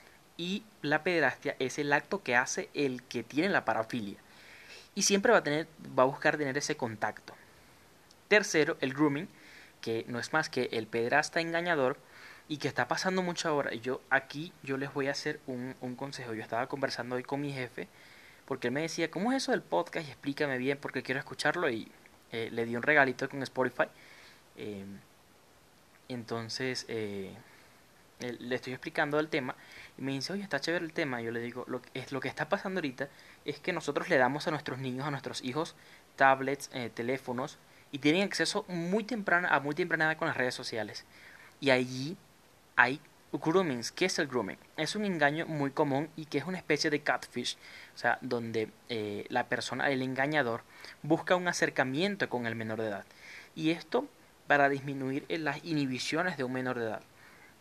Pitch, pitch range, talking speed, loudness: 140 Hz, 125-155 Hz, 190 wpm, -32 LUFS